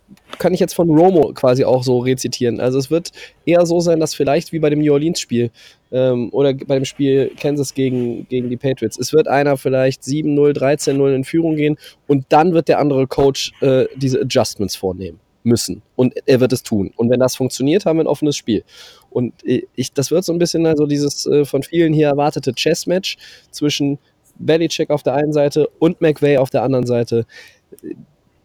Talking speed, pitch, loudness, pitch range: 205 wpm, 140 Hz, -16 LUFS, 125-150 Hz